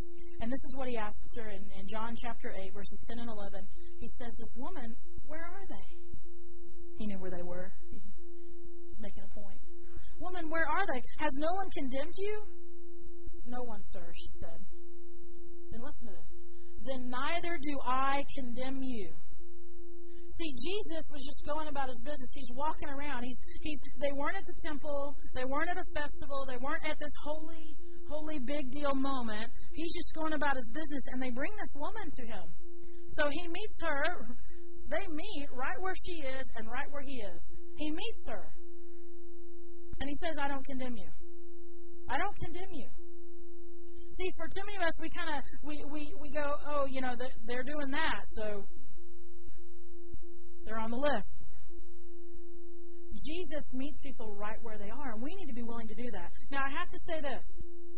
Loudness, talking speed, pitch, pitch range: -39 LUFS, 185 wpm, 310 Hz, 265-345 Hz